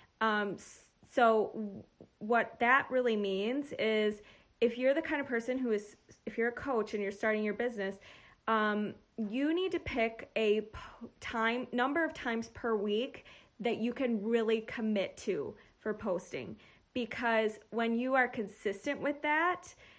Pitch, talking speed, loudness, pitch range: 230 Hz, 155 wpm, -33 LUFS, 215-255 Hz